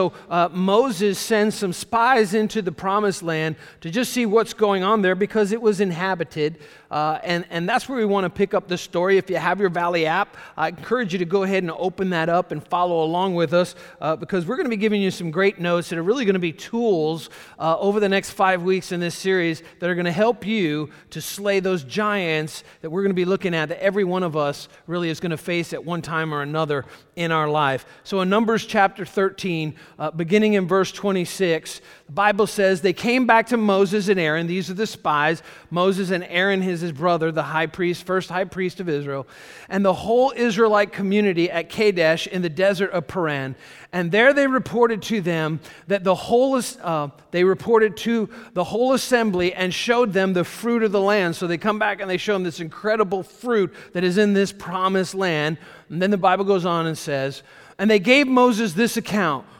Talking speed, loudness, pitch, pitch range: 225 wpm, -21 LUFS, 185 Hz, 170-205 Hz